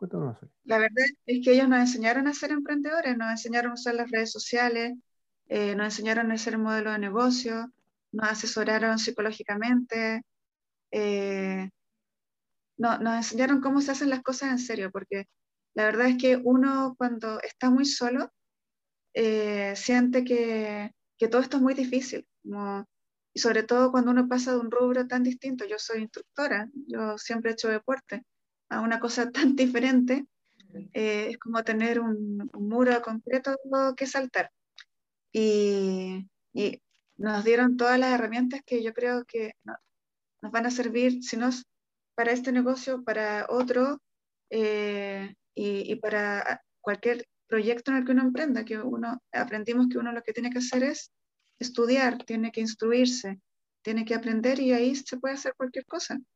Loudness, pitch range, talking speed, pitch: -27 LUFS, 220-255 Hz, 165 wpm, 235 Hz